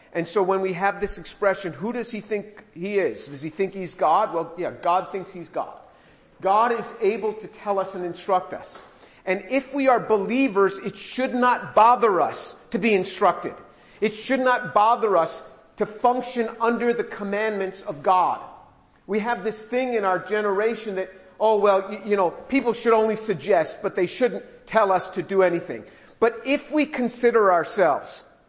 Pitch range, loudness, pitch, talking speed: 190-230 Hz, -23 LUFS, 210 Hz, 185 wpm